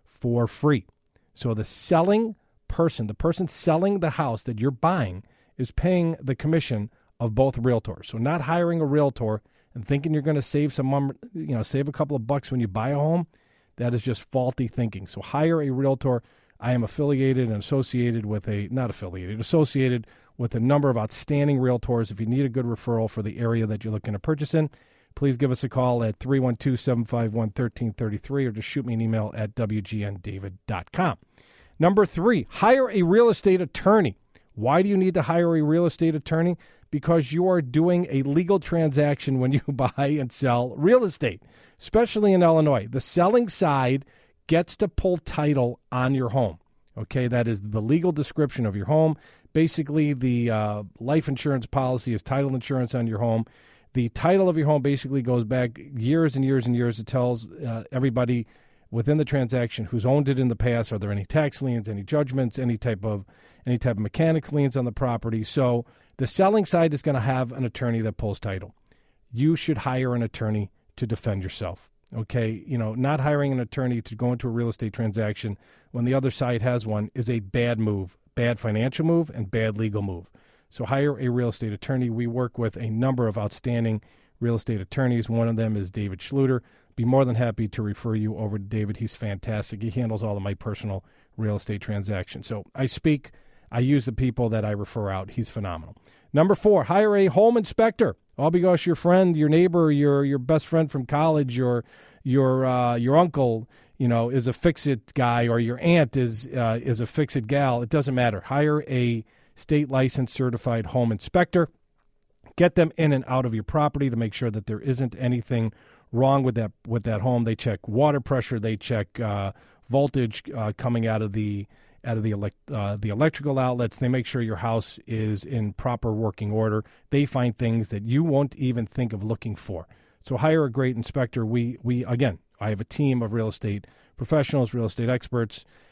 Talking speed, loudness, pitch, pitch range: 200 wpm, -24 LUFS, 125 Hz, 110-145 Hz